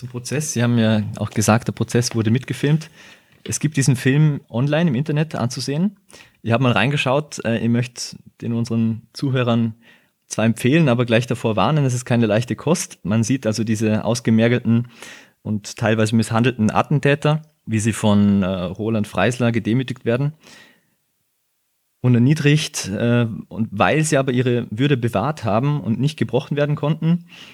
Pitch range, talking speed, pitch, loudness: 110-145 Hz, 150 wpm, 120 Hz, -19 LUFS